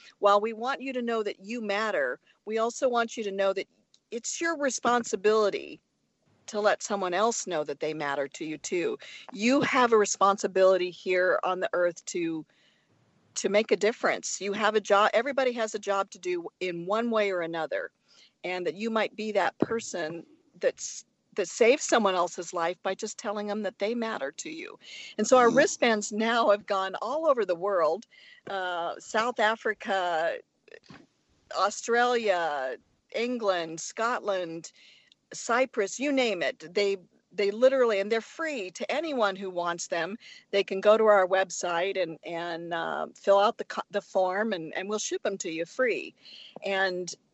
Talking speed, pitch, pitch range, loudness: 170 wpm, 210 Hz, 190-245 Hz, -28 LUFS